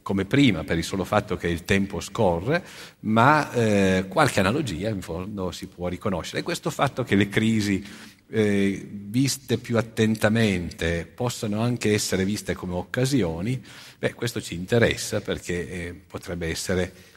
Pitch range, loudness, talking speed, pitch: 90-115 Hz, -24 LUFS, 150 wpm, 100 Hz